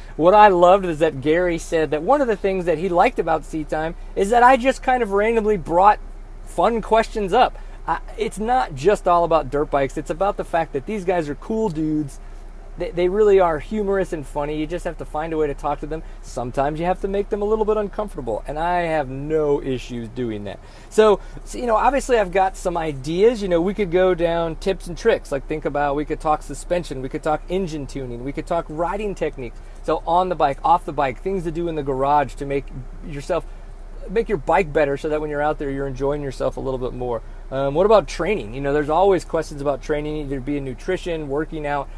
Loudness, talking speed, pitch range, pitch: -21 LUFS, 235 wpm, 140-190 Hz, 160 Hz